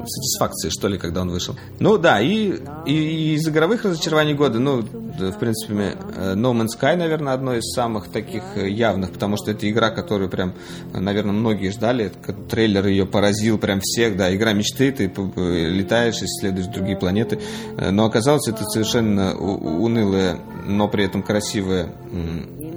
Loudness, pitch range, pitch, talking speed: -21 LUFS, 95-120 Hz, 105 Hz, 160 wpm